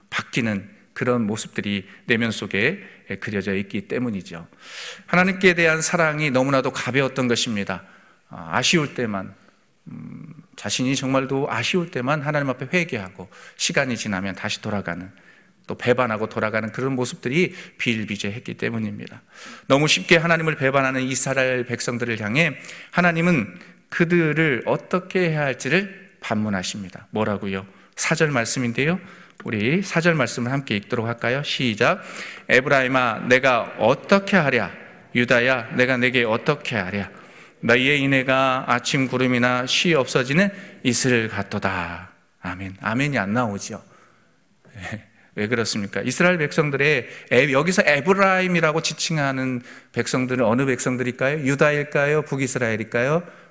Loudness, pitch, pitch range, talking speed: -21 LUFS, 130 Hz, 110-155 Hz, 320 characters per minute